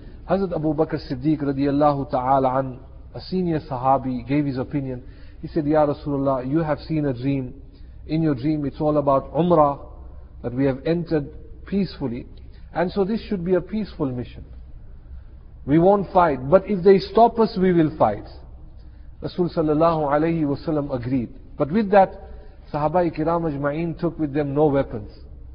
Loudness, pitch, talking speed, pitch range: -22 LUFS, 150 Hz, 160 wpm, 130-165 Hz